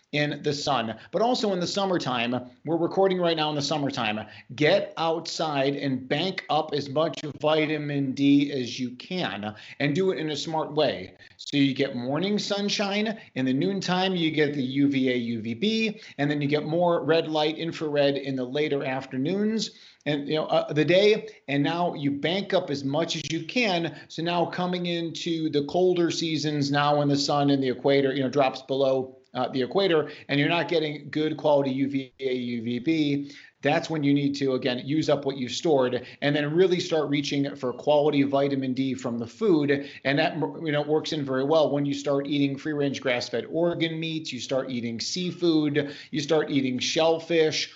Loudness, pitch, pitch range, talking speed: -26 LUFS, 150 Hz, 135-165 Hz, 190 wpm